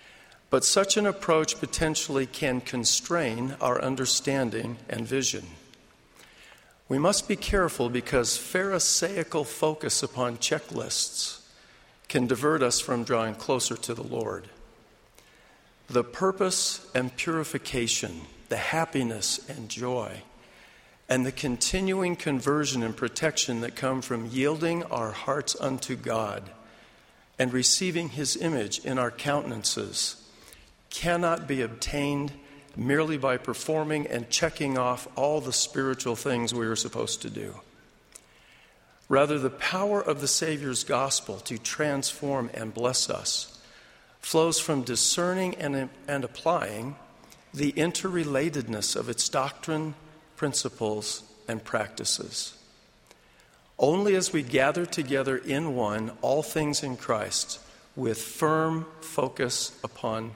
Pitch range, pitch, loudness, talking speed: 120-155 Hz, 135 Hz, -27 LUFS, 115 wpm